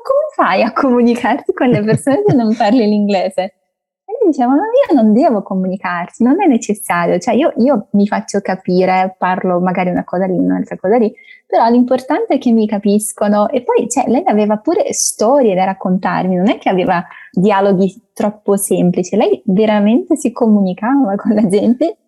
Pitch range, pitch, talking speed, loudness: 190-265 Hz, 215 Hz, 175 wpm, -13 LUFS